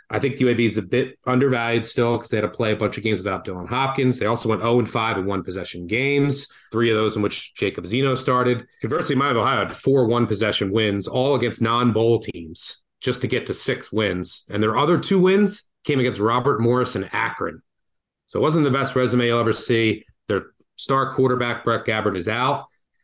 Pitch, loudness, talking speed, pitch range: 120 Hz, -21 LUFS, 210 wpm, 110-130 Hz